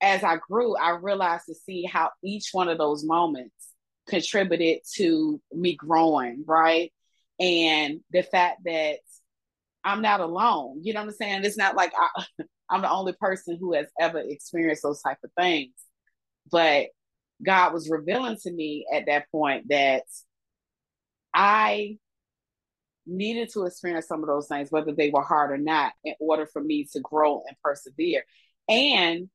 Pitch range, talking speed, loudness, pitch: 155-195 Hz, 160 wpm, -25 LUFS, 170 Hz